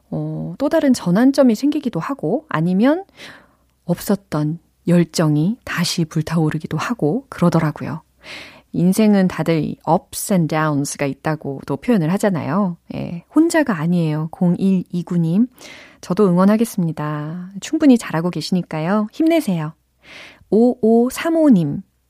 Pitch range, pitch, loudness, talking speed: 160-230 Hz, 180 Hz, -18 LUFS, 275 characters per minute